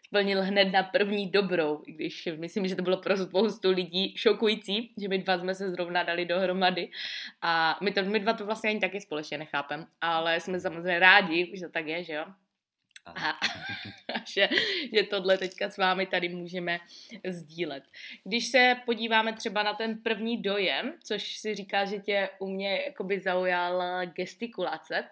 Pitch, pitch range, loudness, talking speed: 190 Hz, 180-215 Hz, -28 LUFS, 170 wpm